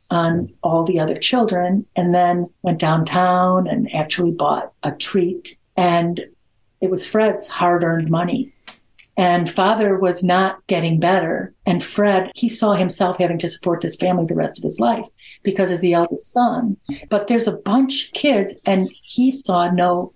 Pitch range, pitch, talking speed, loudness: 175-205 Hz, 185 Hz, 165 wpm, -18 LUFS